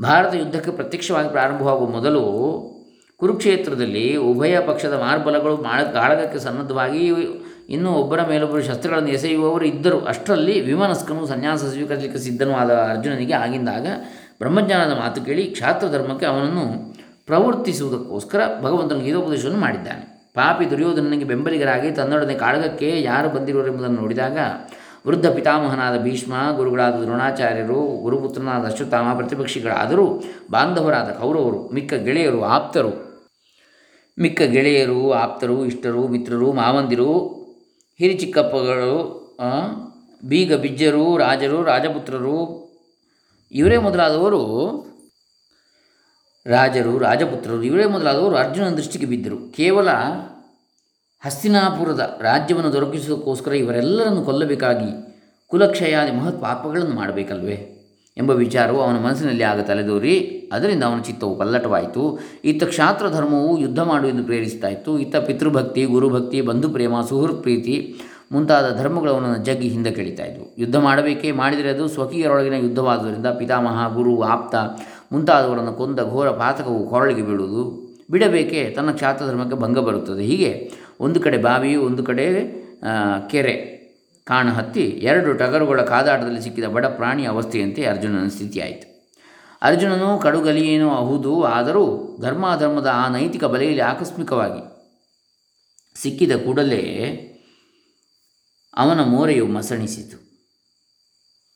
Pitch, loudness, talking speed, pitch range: 135 Hz, -19 LUFS, 100 wpm, 120-155 Hz